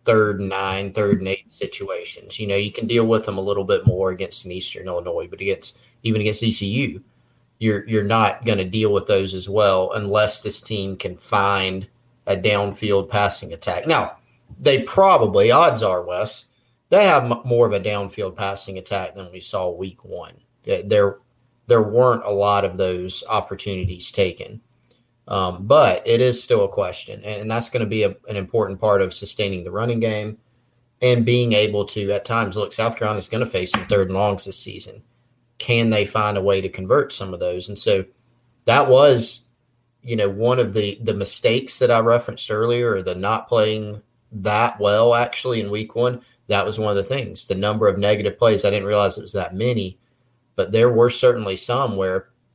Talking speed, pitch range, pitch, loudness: 195 wpm, 100-120 Hz, 110 Hz, -20 LUFS